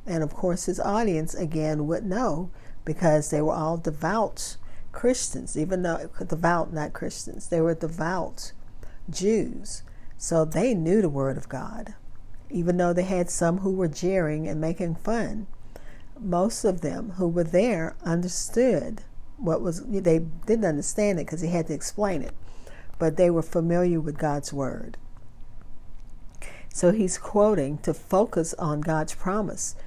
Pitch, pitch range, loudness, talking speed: 165 Hz, 150-185 Hz, -26 LUFS, 150 wpm